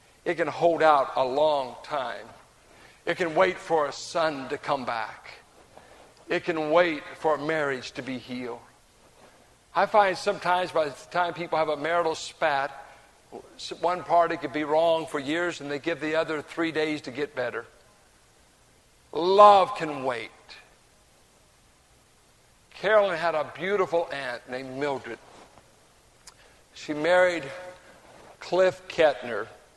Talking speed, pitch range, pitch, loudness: 135 wpm, 145-175 Hz, 160 Hz, -26 LUFS